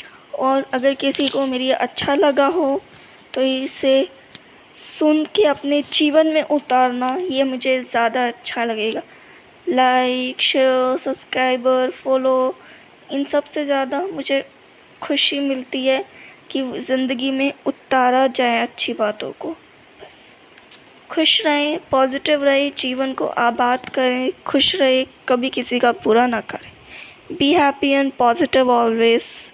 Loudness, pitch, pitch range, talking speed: -18 LUFS, 265 Hz, 255-285 Hz, 130 wpm